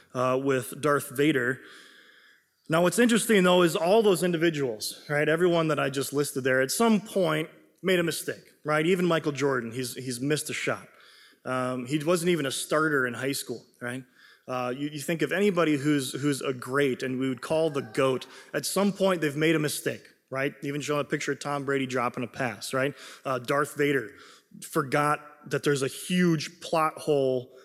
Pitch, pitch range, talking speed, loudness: 145 Hz, 135-170 Hz, 195 wpm, -27 LUFS